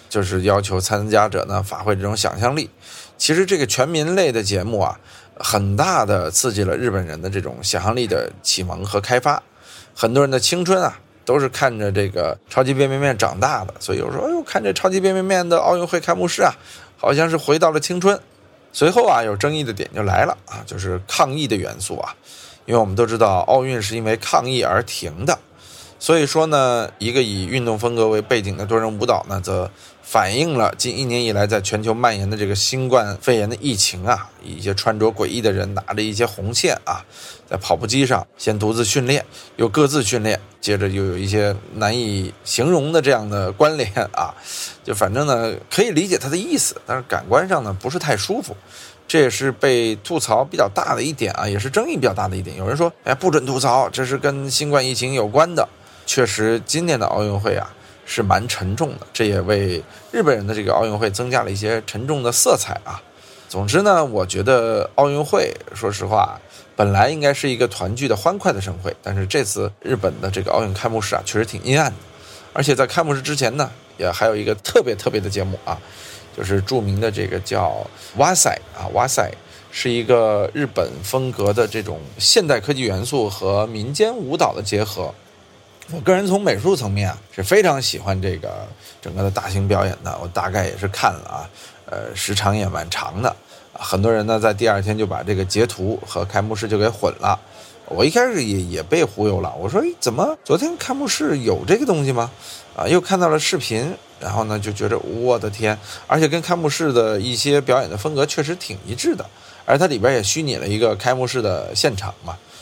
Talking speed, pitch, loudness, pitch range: 310 characters per minute, 110 Hz, -19 LUFS, 100-135 Hz